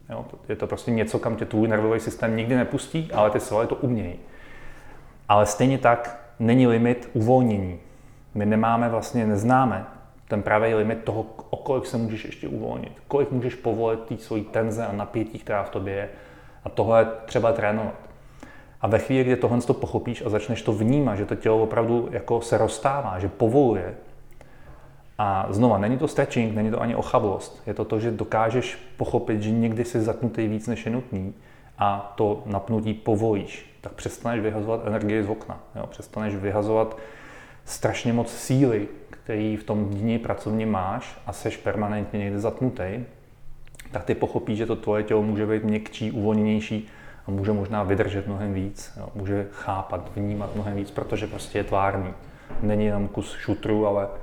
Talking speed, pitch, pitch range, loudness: 175 wpm, 110 Hz, 105-120 Hz, -25 LUFS